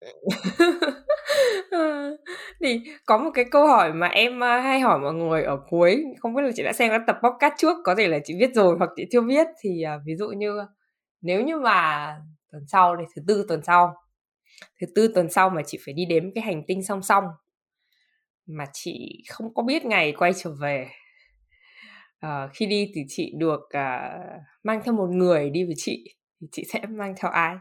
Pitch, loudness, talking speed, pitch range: 200 Hz, -23 LUFS, 200 wpm, 165-245 Hz